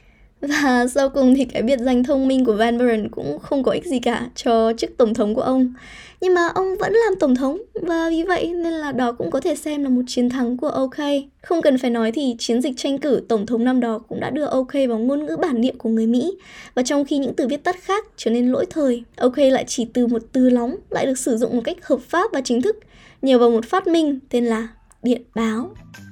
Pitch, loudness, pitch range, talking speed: 260 Hz, -20 LUFS, 240-295 Hz, 255 wpm